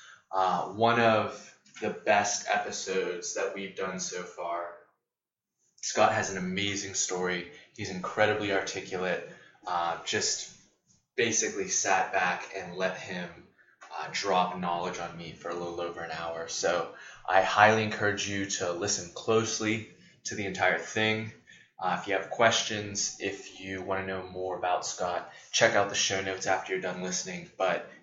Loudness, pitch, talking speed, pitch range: -29 LUFS, 95 Hz, 155 wpm, 90-105 Hz